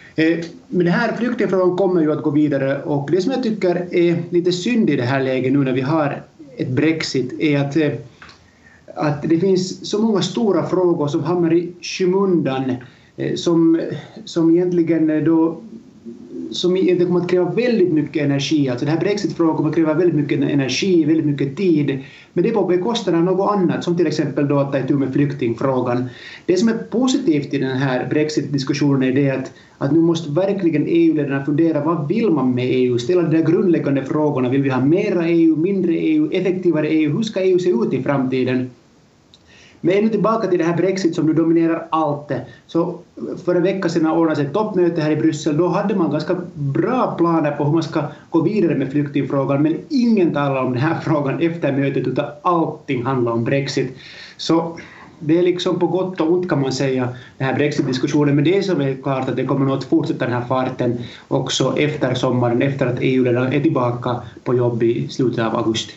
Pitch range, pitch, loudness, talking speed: 140-175 Hz, 155 Hz, -18 LUFS, 200 wpm